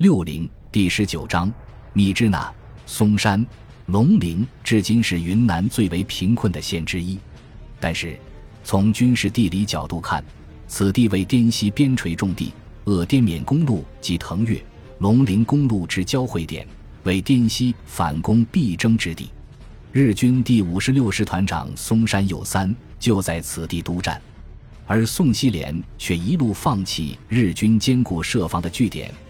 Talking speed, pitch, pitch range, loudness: 220 characters per minute, 100 Hz, 85-115 Hz, -20 LUFS